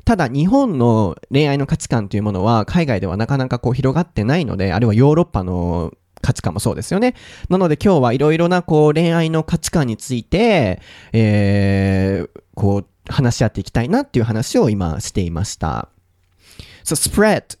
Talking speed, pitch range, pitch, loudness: 385 characters per minute, 100-150 Hz, 115 Hz, -17 LUFS